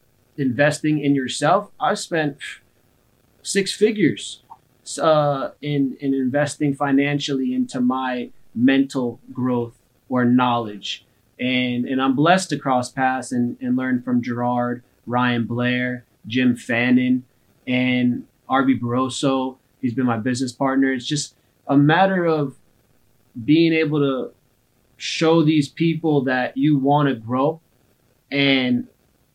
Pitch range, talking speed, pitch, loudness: 125-145 Hz, 120 wpm, 130 Hz, -20 LUFS